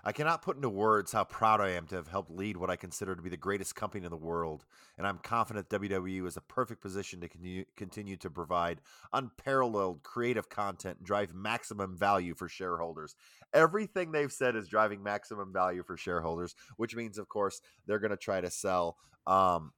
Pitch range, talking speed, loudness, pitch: 90-110 Hz, 200 wpm, -34 LUFS, 100 Hz